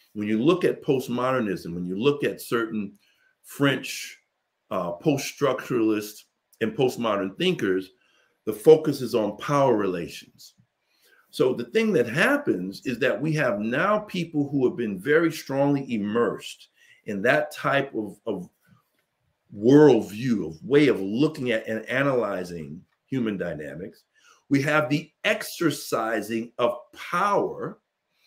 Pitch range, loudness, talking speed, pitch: 110-155 Hz, -24 LUFS, 125 wpm, 130 Hz